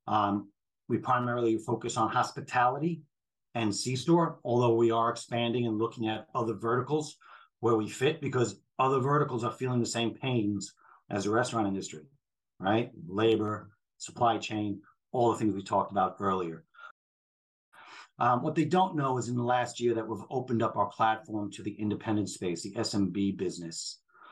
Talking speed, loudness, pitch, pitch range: 165 wpm, -30 LUFS, 115 Hz, 105-125 Hz